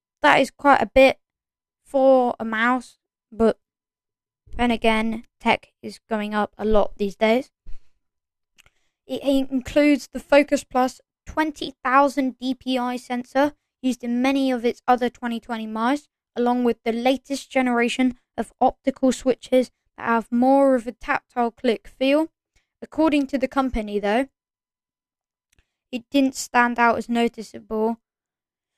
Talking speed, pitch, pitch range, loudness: 130 wpm, 250 Hz, 230-270 Hz, -22 LUFS